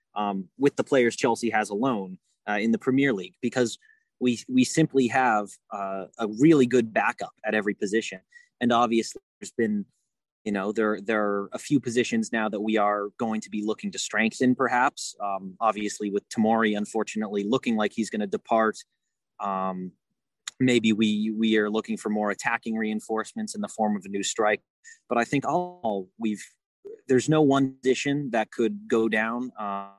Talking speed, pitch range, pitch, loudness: 180 wpm, 105-125 Hz, 110 Hz, -26 LUFS